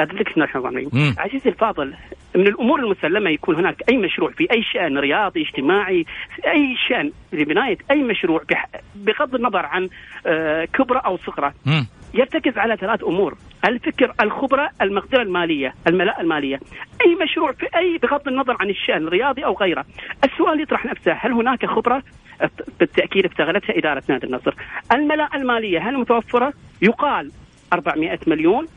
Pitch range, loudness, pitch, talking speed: 180-290 Hz, -19 LUFS, 235 Hz, 135 wpm